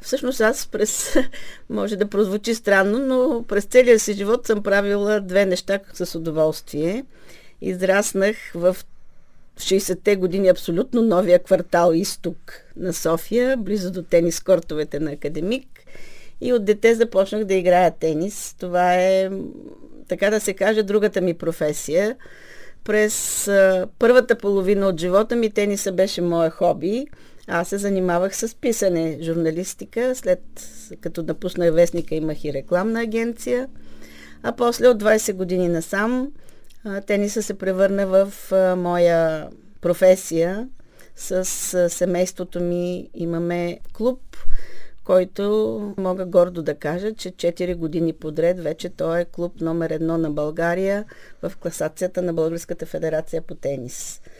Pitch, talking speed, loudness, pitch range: 185 Hz, 130 wpm, -21 LUFS, 170-210 Hz